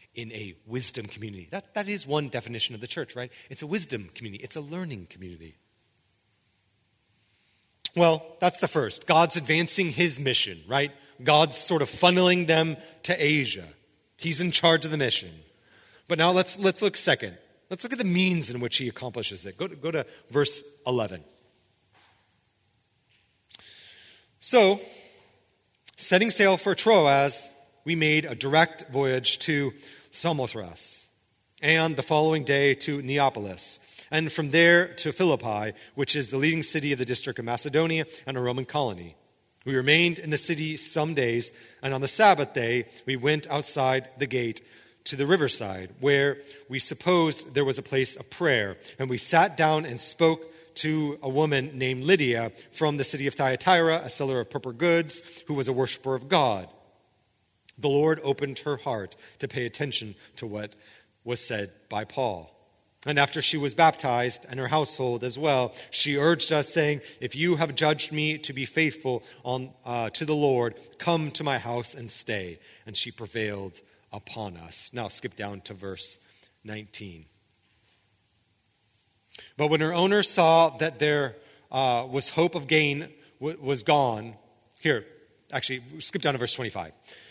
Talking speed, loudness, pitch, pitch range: 170 wpm, -25 LUFS, 135 Hz, 115-155 Hz